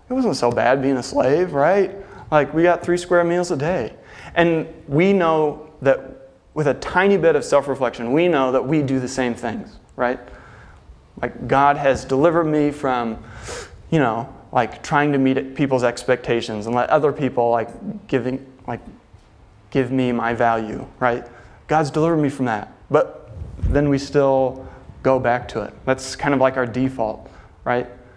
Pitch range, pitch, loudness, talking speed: 120-150 Hz, 130 Hz, -20 LUFS, 175 wpm